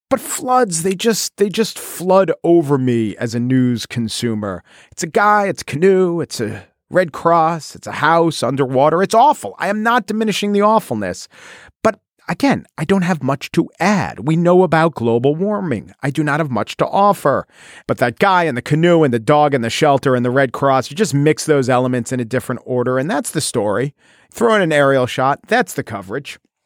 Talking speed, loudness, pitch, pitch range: 205 wpm, -16 LUFS, 150 Hz, 125-190 Hz